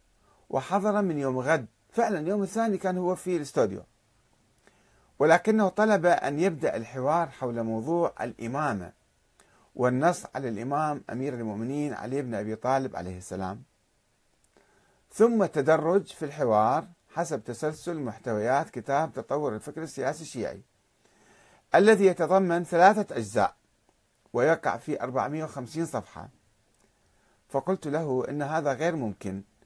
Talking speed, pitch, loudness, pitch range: 115 wpm, 145 Hz, -27 LUFS, 115-175 Hz